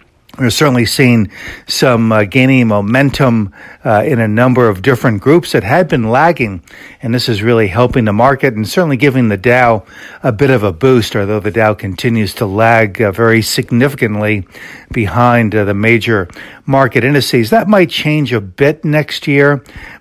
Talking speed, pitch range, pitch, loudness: 170 wpm, 110-135 Hz, 120 Hz, -11 LUFS